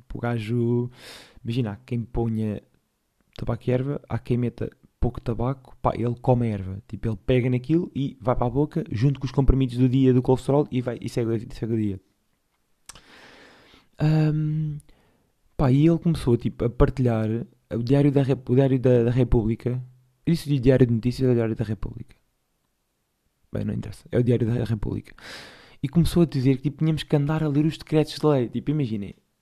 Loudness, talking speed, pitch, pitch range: -24 LUFS, 195 wpm, 125 Hz, 115-140 Hz